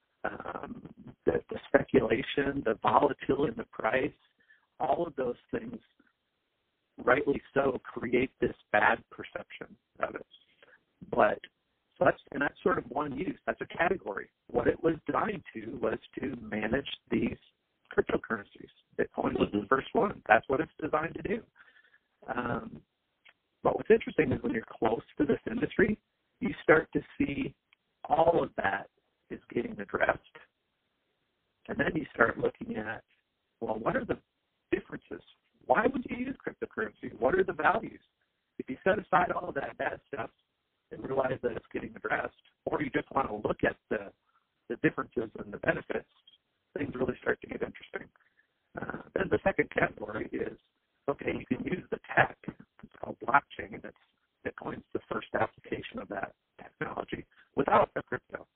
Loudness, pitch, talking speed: -31 LUFS, 160 Hz, 160 wpm